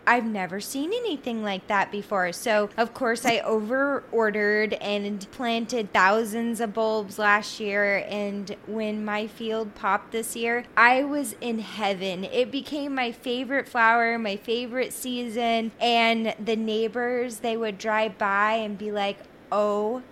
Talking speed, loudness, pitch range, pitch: 150 wpm, -25 LUFS, 205-240 Hz, 225 Hz